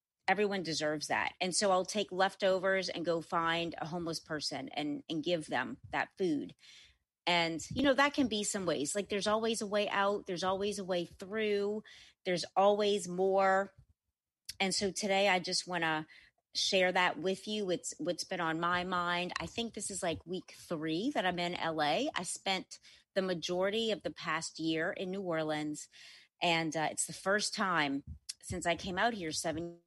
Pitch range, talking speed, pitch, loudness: 165-200 Hz, 185 wpm, 180 Hz, -34 LUFS